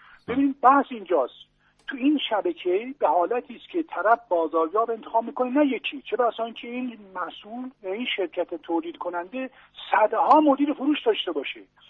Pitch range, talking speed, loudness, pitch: 185-270 Hz, 155 wpm, -24 LUFS, 240 Hz